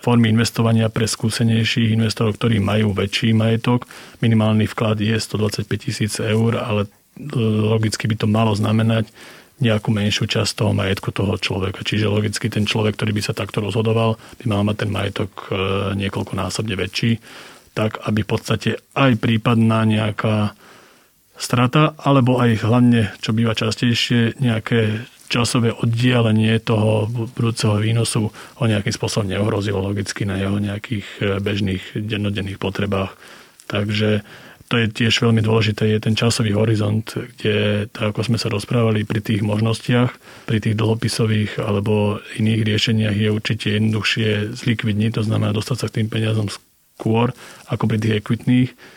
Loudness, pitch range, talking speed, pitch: -19 LUFS, 105-115 Hz, 140 wpm, 110 Hz